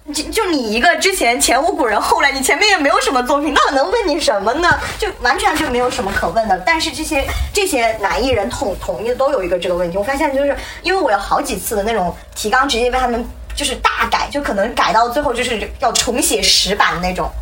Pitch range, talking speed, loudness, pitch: 225-310 Hz, 360 characters per minute, -15 LUFS, 260 Hz